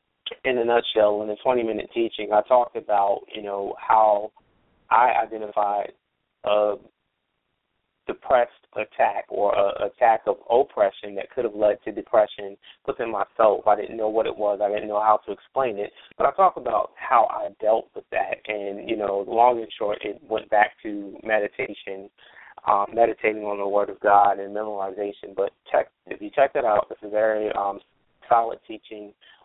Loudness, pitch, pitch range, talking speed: -23 LUFS, 105 Hz, 100-110 Hz, 175 wpm